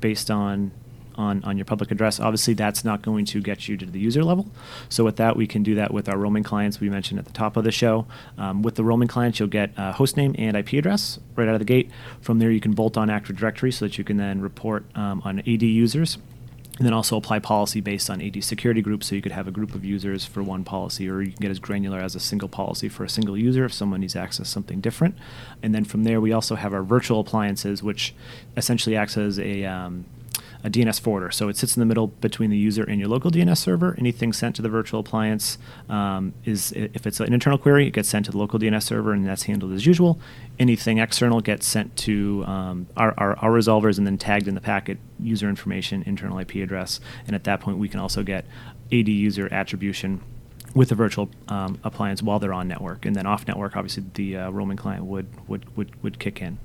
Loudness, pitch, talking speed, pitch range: -23 LUFS, 110 Hz, 245 wpm, 100-115 Hz